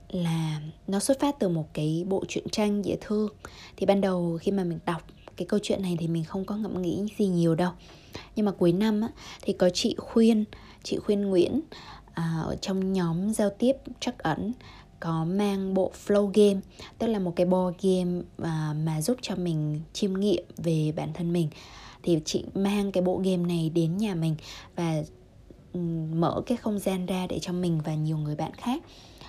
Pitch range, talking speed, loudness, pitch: 170-205 Hz, 195 wpm, -28 LUFS, 185 Hz